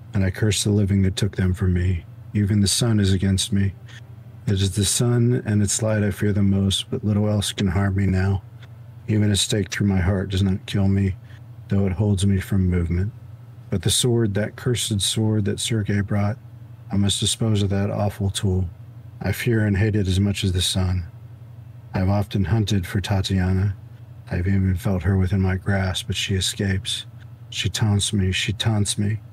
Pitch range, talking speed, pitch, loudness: 95-115 Hz, 205 wpm, 105 Hz, -22 LUFS